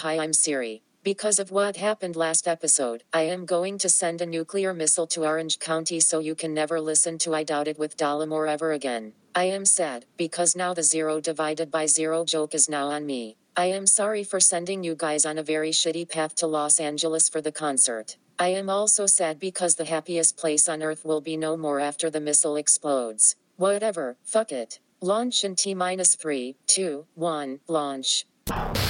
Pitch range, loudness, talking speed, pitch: 155-180 Hz, -23 LUFS, 195 wpm, 160 Hz